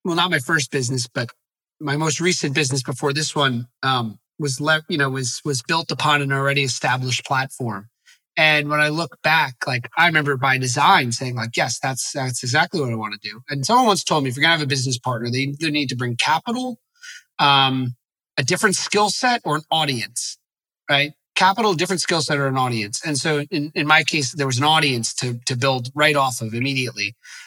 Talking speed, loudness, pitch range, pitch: 215 wpm, -20 LUFS, 130-160 Hz, 145 Hz